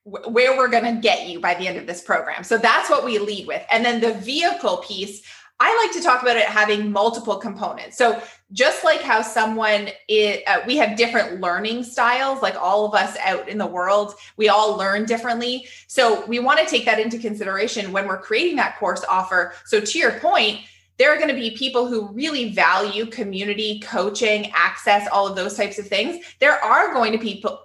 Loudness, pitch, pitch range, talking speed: -19 LUFS, 220 Hz, 205-245 Hz, 215 wpm